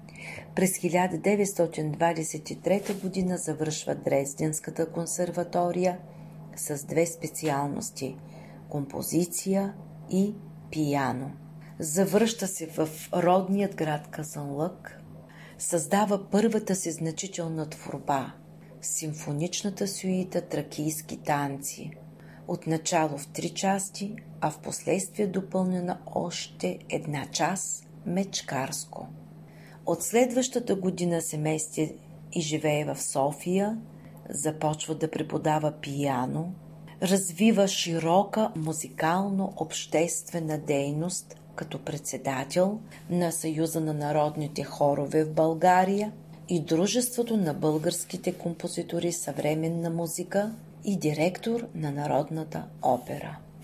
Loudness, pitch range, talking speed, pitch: -29 LUFS, 155-185 Hz, 85 wpm, 165 Hz